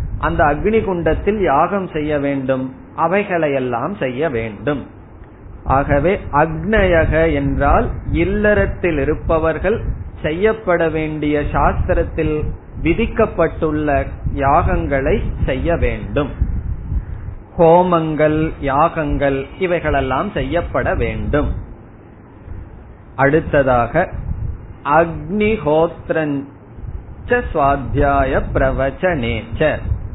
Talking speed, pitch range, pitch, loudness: 55 wpm, 115-165 Hz, 145 Hz, -17 LUFS